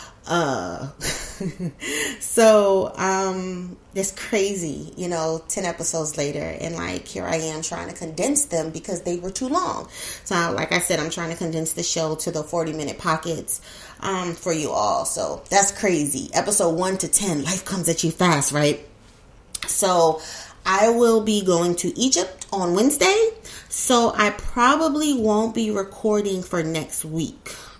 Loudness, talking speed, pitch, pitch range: -22 LUFS, 160 wpm, 180 Hz, 160-200 Hz